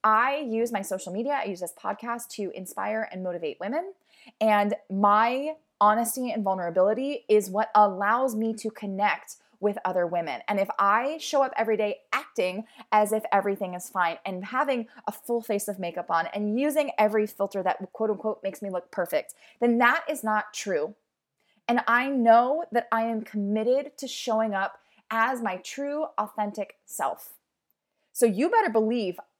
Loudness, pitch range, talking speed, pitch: -26 LUFS, 205-240 Hz, 170 wpm, 215 Hz